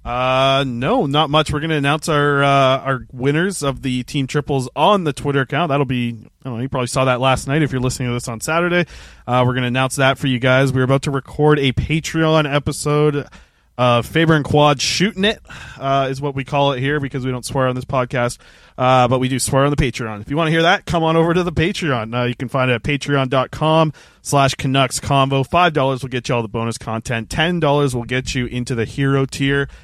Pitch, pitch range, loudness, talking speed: 135 Hz, 130-150 Hz, -17 LUFS, 240 wpm